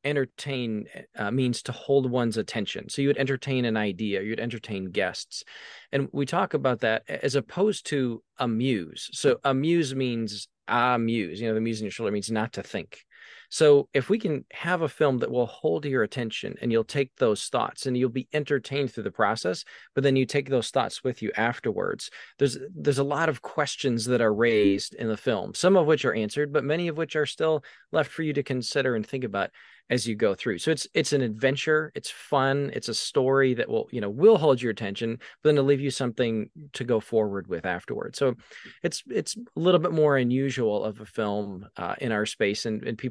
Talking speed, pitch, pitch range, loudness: 215 wpm, 130 Hz, 115-145 Hz, -26 LUFS